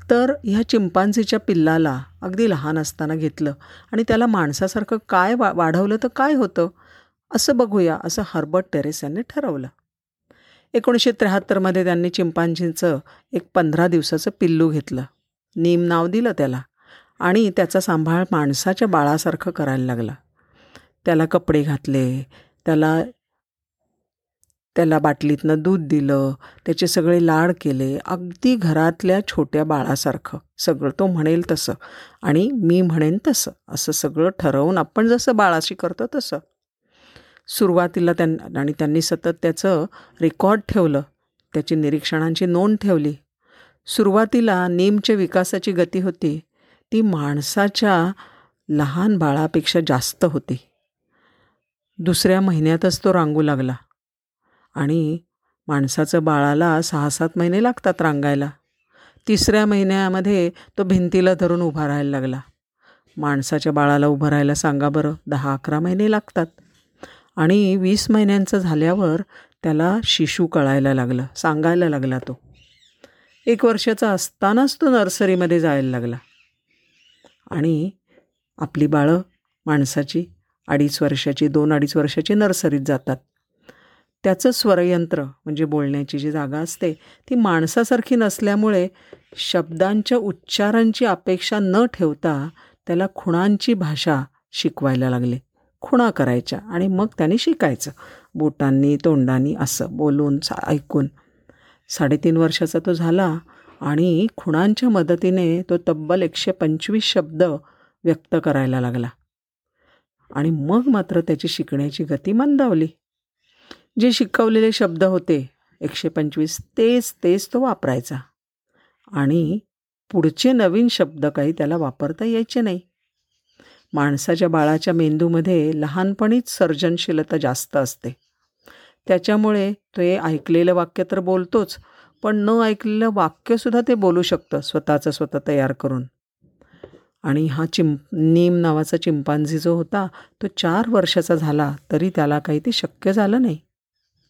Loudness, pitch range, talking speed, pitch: -19 LUFS, 150-195 Hz, 115 wpm, 170 Hz